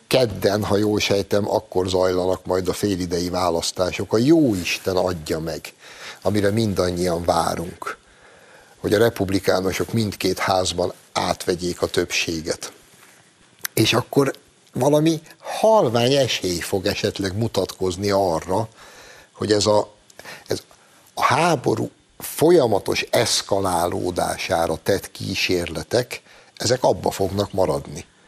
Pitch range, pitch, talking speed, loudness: 90-105 Hz, 95 Hz, 105 wpm, -21 LUFS